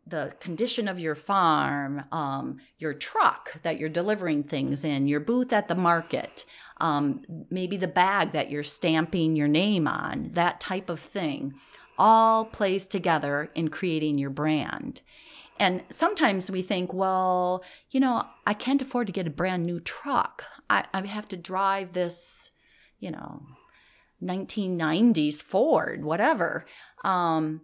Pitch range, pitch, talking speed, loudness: 155-195 Hz, 180 Hz, 145 wpm, -26 LUFS